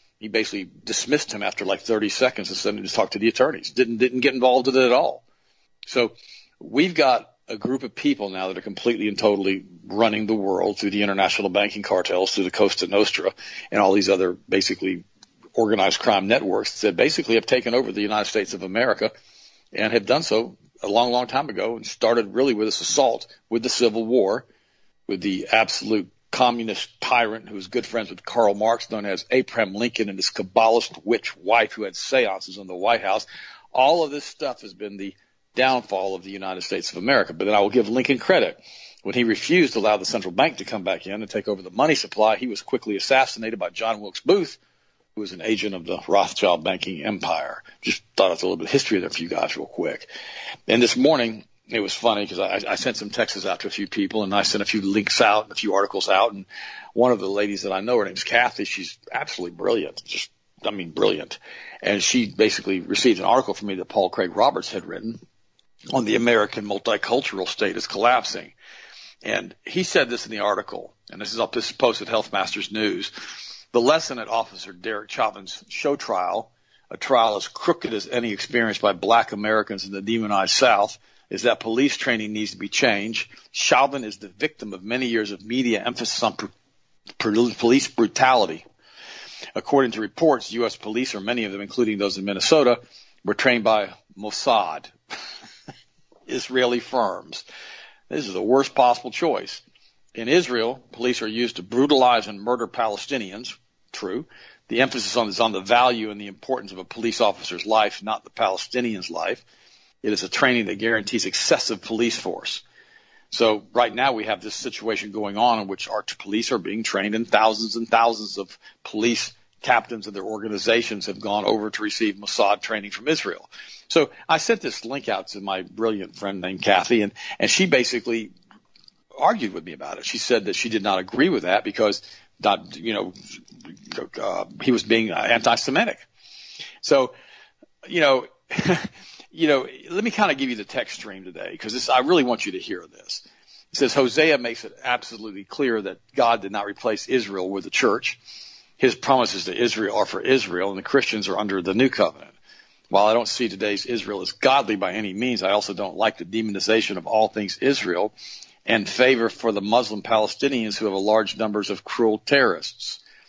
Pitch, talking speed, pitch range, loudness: 110 Hz, 200 wpm, 100-125 Hz, -22 LUFS